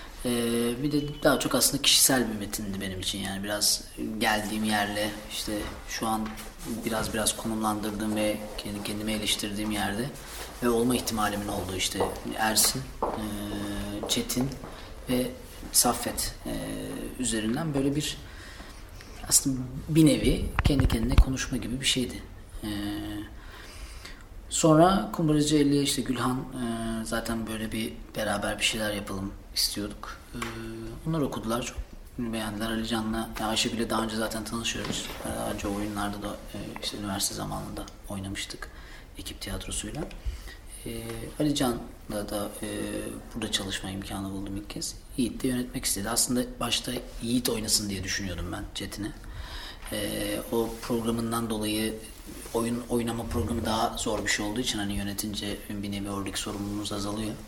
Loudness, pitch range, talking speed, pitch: -28 LUFS, 100-120 Hz, 125 wpm, 110 Hz